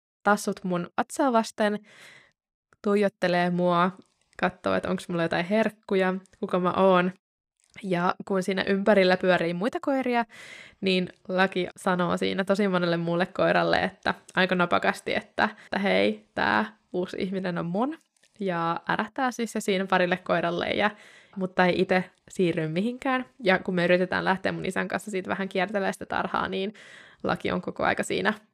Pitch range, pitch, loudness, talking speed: 180-210 Hz, 190 Hz, -26 LUFS, 150 wpm